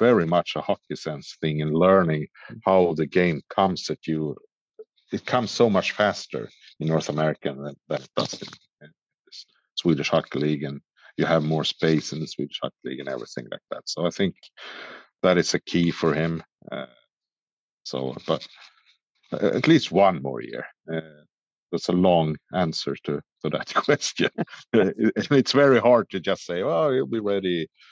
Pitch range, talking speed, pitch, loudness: 80-95 Hz, 175 wpm, 80 Hz, -24 LUFS